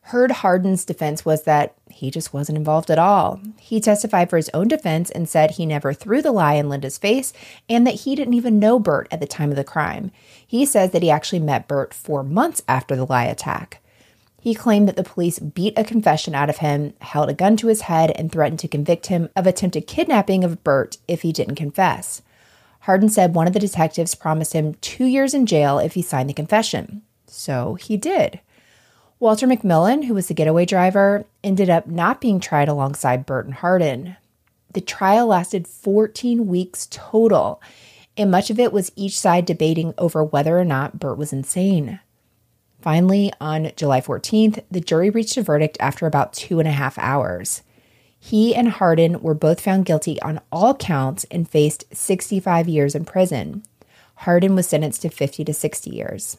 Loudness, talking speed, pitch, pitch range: -19 LUFS, 195 wpm, 170 Hz, 150-205 Hz